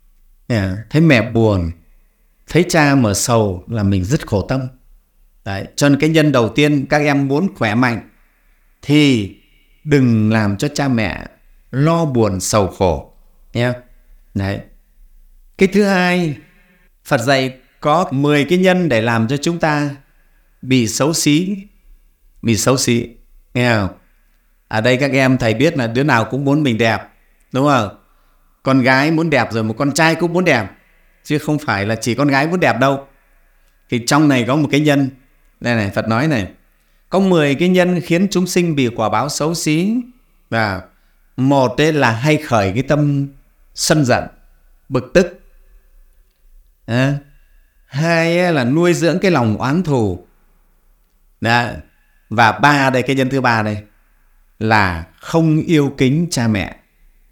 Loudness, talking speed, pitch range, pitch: -16 LUFS, 165 wpm, 110-155 Hz, 135 Hz